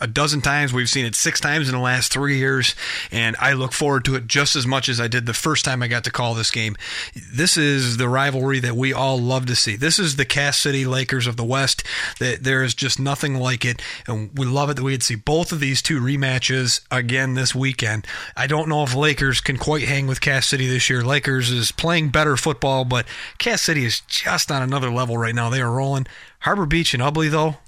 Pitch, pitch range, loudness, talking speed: 130 Hz, 125-145 Hz, -19 LUFS, 240 wpm